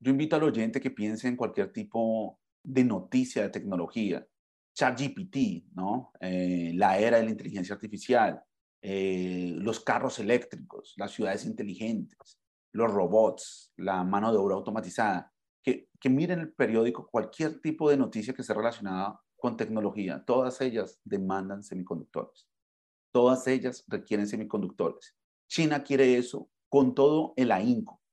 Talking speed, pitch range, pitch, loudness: 140 wpm, 100-140 Hz, 115 Hz, -29 LUFS